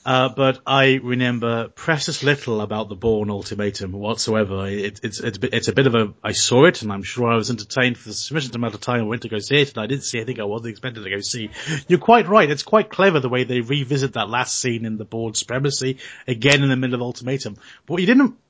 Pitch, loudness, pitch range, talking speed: 125 Hz, -20 LUFS, 110-135 Hz, 260 wpm